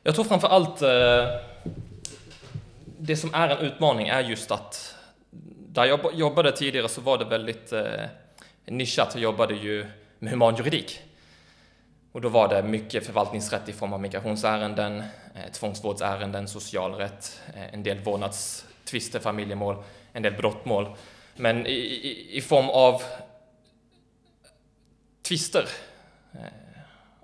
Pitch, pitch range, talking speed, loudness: 110 Hz, 100-130 Hz, 110 wpm, -25 LUFS